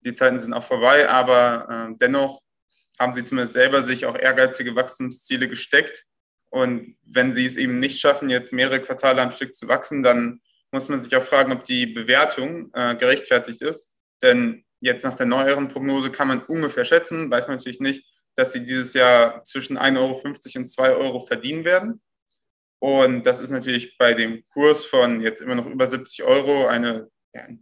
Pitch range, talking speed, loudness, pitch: 125-135 Hz, 185 wpm, -20 LUFS, 130 Hz